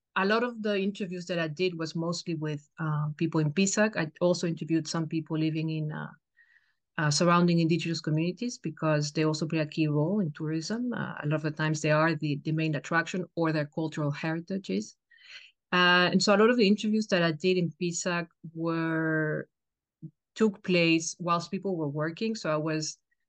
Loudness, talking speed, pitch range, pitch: -28 LUFS, 195 wpm, 155-190 Hz, 165 Hz